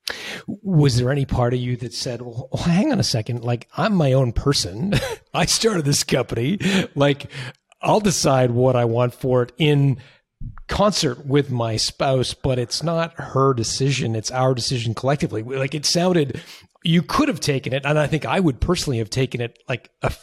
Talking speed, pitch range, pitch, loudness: 185 wpm, 125-160 Hz, 135 Hz, -20 LUFS